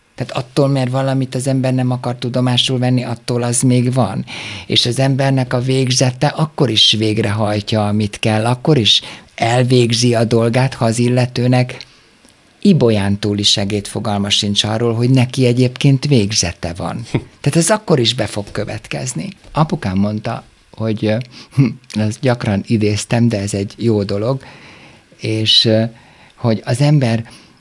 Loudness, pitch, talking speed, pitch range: -15 LUFS, 120 Hz, 145 wpm, 105-130 Hz